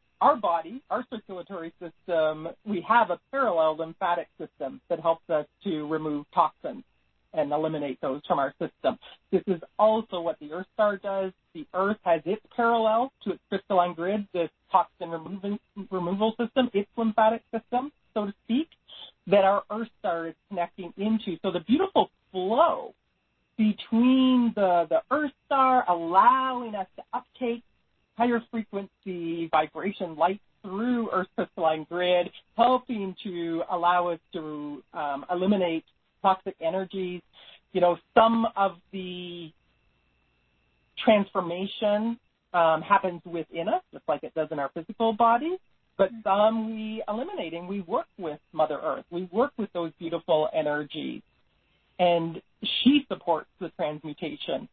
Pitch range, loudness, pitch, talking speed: 170-220 Hz, -27 LUFS, 190 Hz, 140 wpm